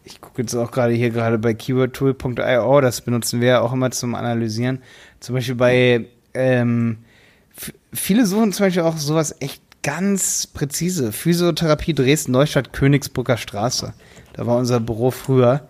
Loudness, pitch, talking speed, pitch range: -19 LUFS, 130 Hz, 155 wpm, 120-145 Hz